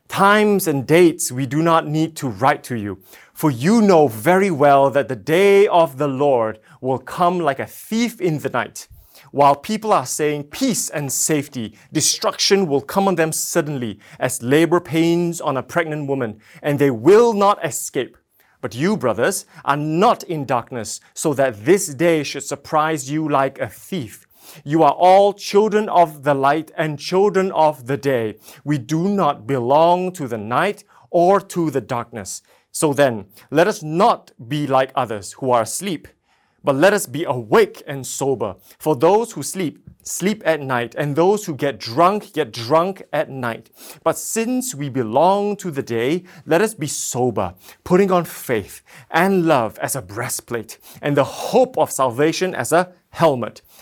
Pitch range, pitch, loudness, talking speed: 135-175 Hz, 155 Hz, -18 LUFS, 175 wpm